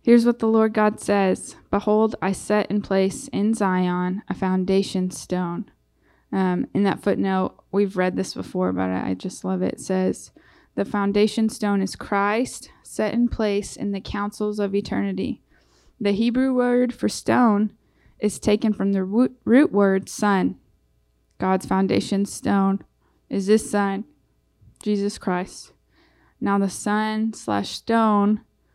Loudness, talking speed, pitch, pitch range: -22 LUFS, 145 wpm, 200 Hz, 190-215 Hz